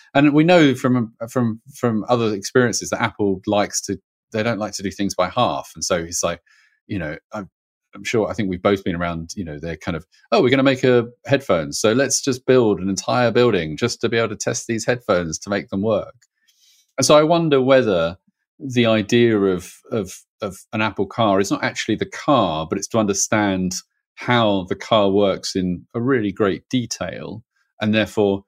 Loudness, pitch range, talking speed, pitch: -19 LUFS, 100-125 Hz, 210 wpm, 110 Hz